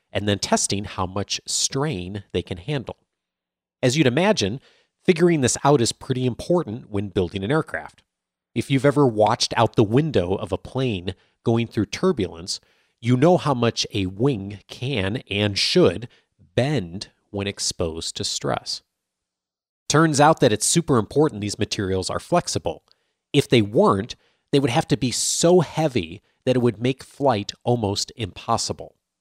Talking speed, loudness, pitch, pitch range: 155 wpm, -22 LUFS, 120 Hz, 100-145 Hz